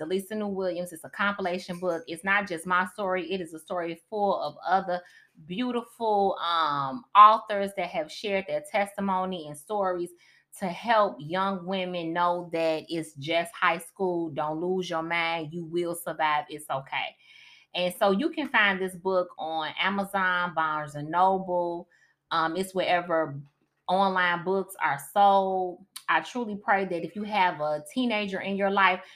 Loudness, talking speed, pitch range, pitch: -27 LUFS, 165 wpm, 170-195 Hz, 180 Hz